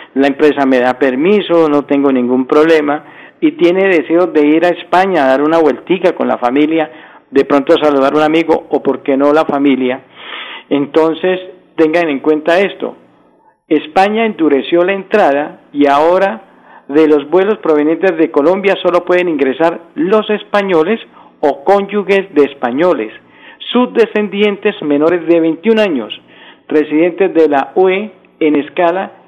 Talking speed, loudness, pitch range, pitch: 150 wpm, -12 LUFS, 145-190 Hz, 160 Hz